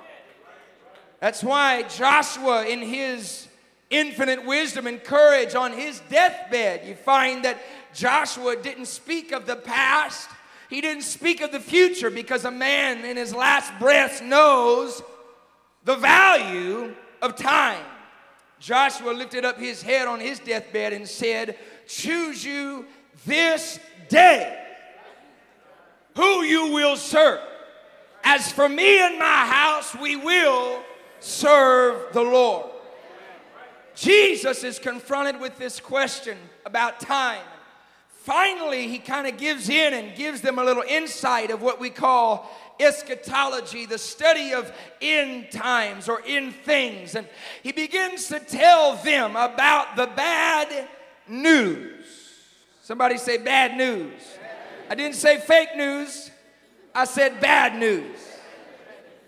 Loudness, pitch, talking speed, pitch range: -20 LUFS, 270 Hz, 125 wpm, 245-300 Hz